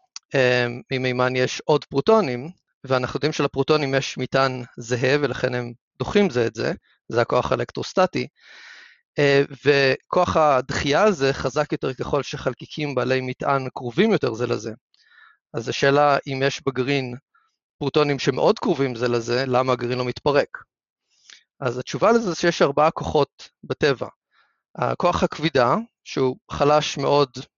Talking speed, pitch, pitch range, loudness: 125 wpm, 140 Hz, 125-150 Hz, -22 LUFS